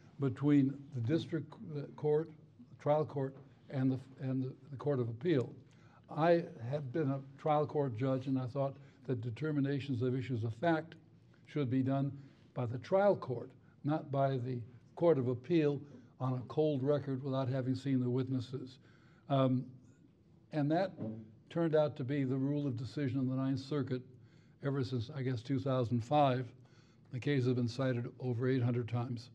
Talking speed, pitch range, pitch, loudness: 170 wpm, 125-145 Hz, 135 Hz, -36 LUFS